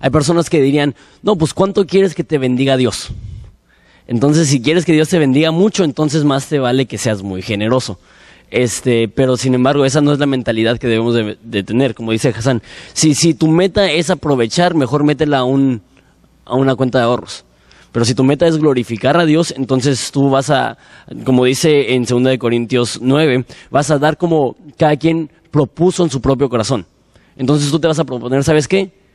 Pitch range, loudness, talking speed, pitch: 125-155 Hz, -14 LUFS, 200 wpm, 135 Hz